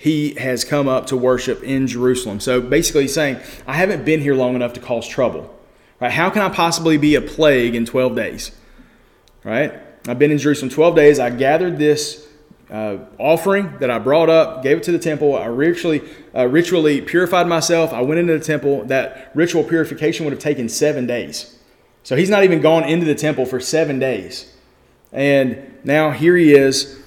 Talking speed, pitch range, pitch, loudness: 195 wpm, 130-160 Hz, 150 Hz, -16 LUFS